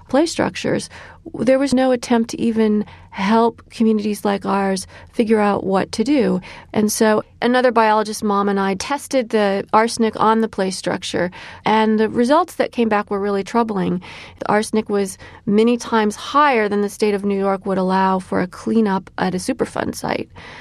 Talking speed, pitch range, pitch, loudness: 180 wpm, 195-235 Hz, 215 Hz, -18 LUFS